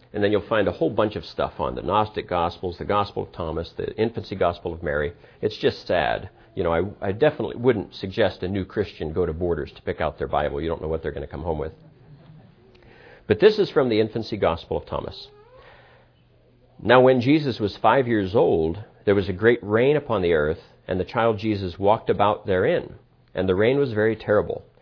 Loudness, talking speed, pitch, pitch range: -23 LUFS, 220 wpm, 105 Hz, 90-130 Hz